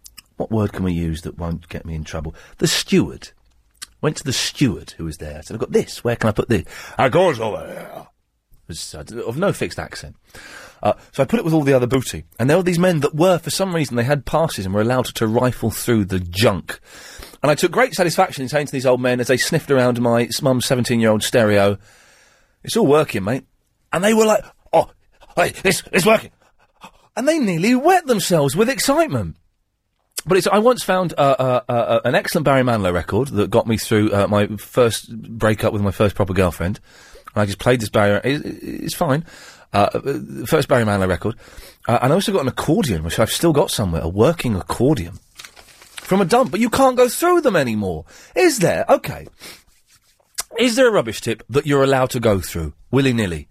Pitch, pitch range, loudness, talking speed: 120 Hz, 100-160 Hz, -18 LUFS, 215 wpm